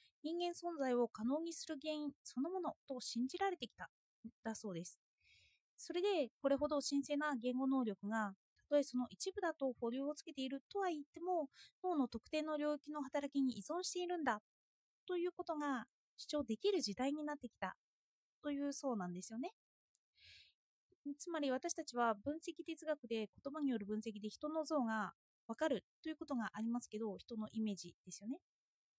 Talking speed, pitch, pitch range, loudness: 345 characters per minute, 280 Hz, 230-315 Hz, -42 LUFS